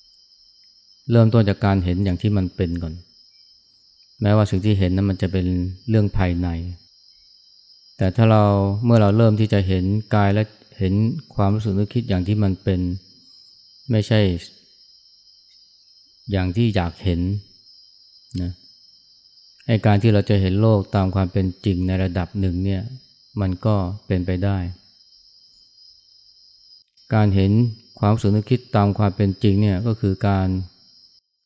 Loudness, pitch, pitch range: -20 LUFS, 100 Hz, 95-105 Hz